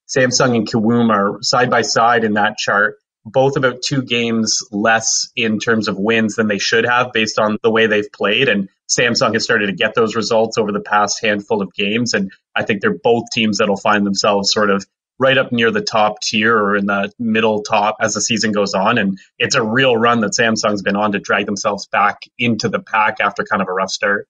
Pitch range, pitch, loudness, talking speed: 105-120 Hz, 110 Hz, -15 LUFS, 230 wpm